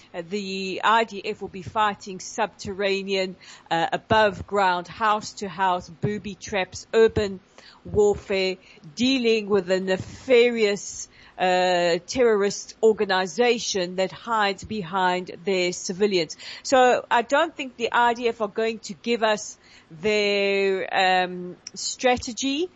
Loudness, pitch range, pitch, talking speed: -23 LUFS, 185-225 Hz, 205 Hz, 115 wpm